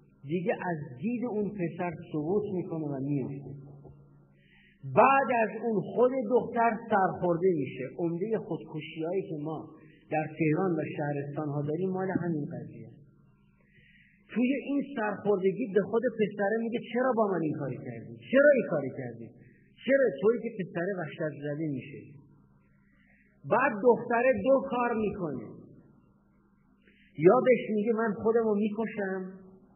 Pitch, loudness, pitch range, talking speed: 185 Hz, -29 LUFS, 150-225 Hz, 135 wpm